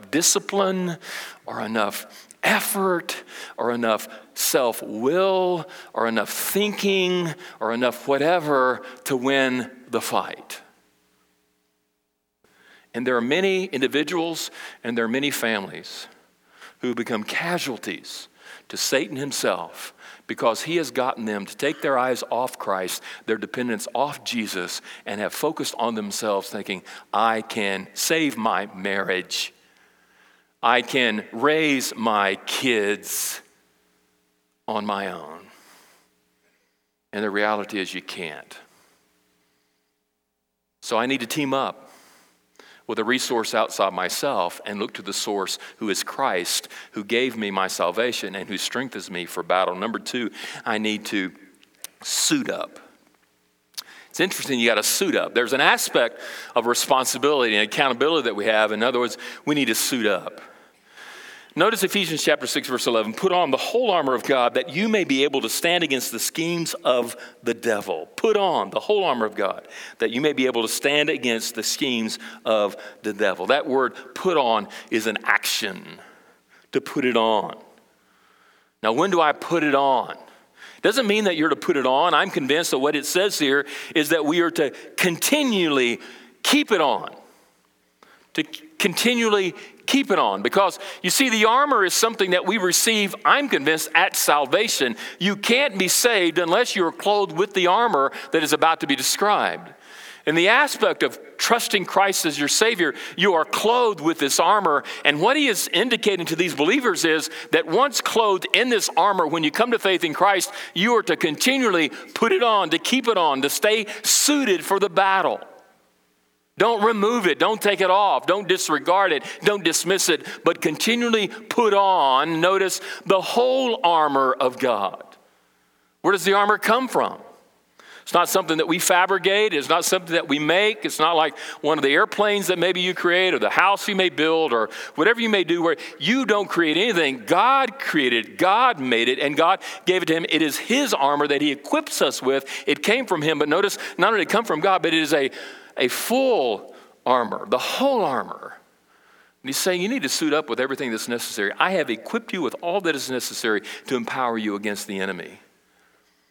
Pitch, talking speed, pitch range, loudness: 160 Hz, 175 wpm, 120-195 Hz, -21 LUFS